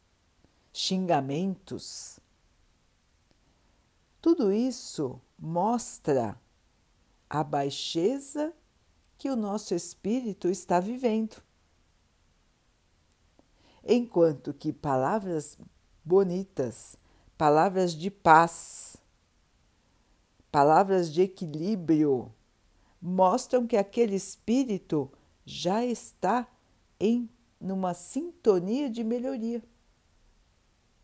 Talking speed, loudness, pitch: 65 wpm, -28 LUFS, 180 Hz